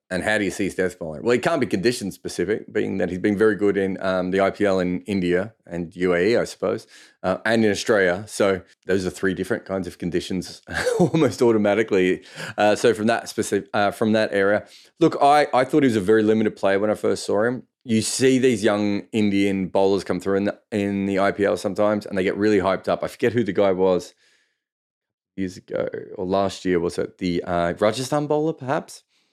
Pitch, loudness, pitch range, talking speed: 100 Hz, -22 LUFS, 95-110 Hz, 215 wpm